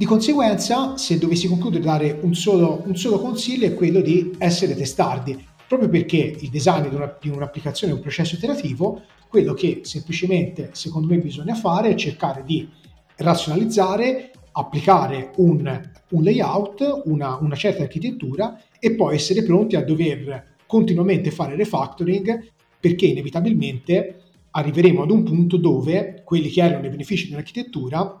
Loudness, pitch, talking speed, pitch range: -20 LUFS, 175 Hz, 145 wpm, 155-200 Hz